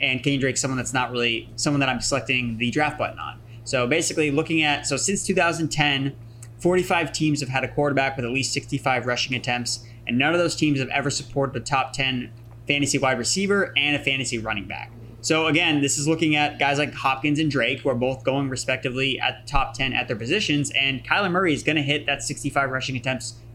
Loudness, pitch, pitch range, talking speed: -22 LUFS, 135 Hz, 125-145 Hz, 220 wpm